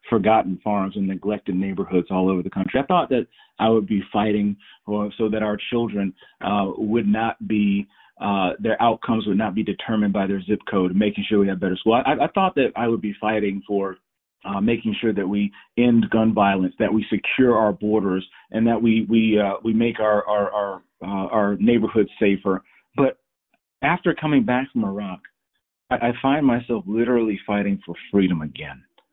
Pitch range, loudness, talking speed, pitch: 100-115 Hz, -21 LUFS, 190 wpm, 105 Hz